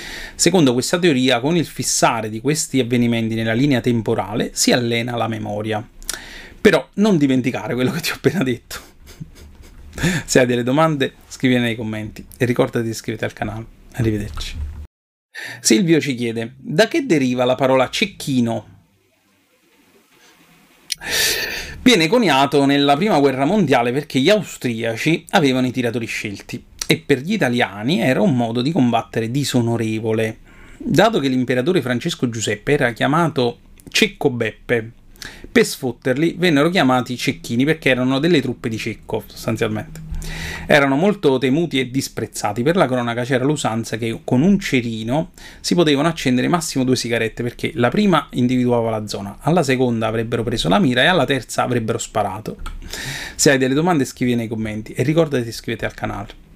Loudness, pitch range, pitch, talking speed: -18 LUFS, 115-140 Hz, 125 Hz, 150 wpm